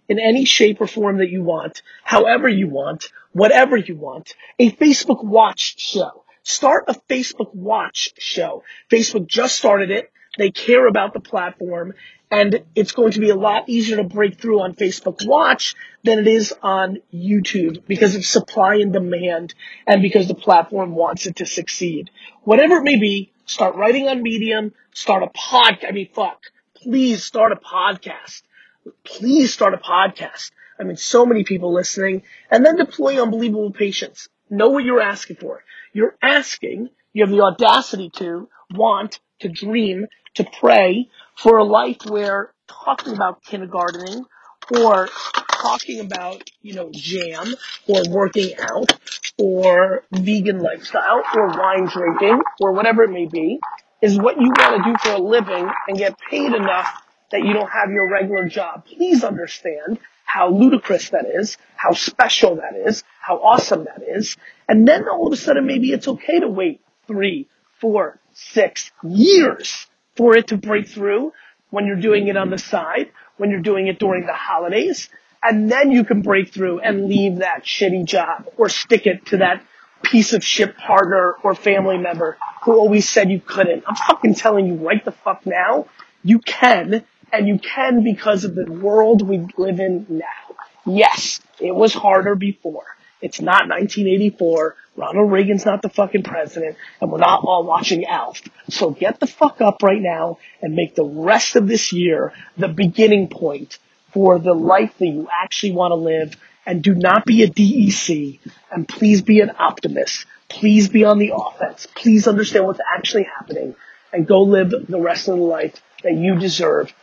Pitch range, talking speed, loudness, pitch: 190-225 Hz, 170 wpm, -17 LUFS, 205 Hz